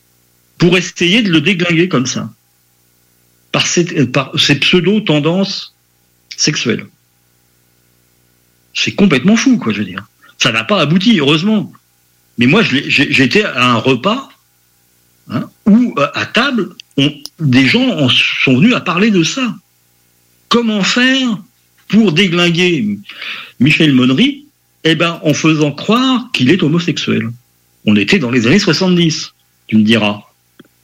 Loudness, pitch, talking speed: -12 LUFS, 145 Hz, 130 wpm